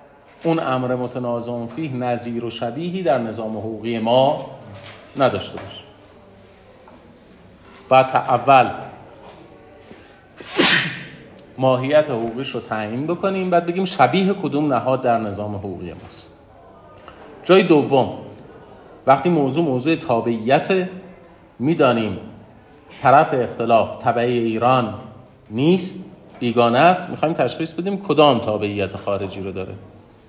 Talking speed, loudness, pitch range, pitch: 105 wpm, -19 LUFS, 110-160 Hz, 125 Hz